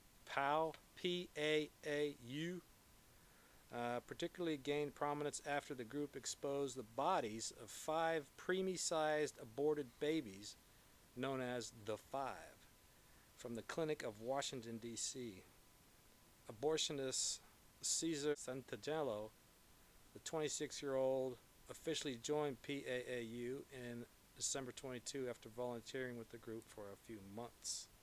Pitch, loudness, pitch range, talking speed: 135 Hz, -44 LUFS, 120-150 Hz, 100 wpm